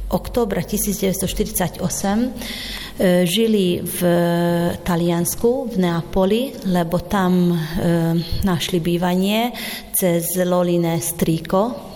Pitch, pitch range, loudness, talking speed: 180 Hz, 175-210 Hz, -19 LUFS, 85 wpm